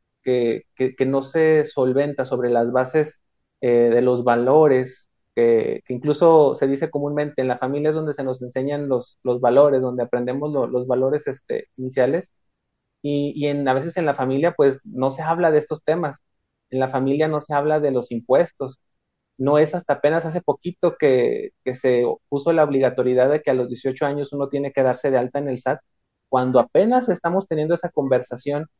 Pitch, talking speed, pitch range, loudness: 140 Hz, 195 wpm, 130-155 Hz, -20 LUFS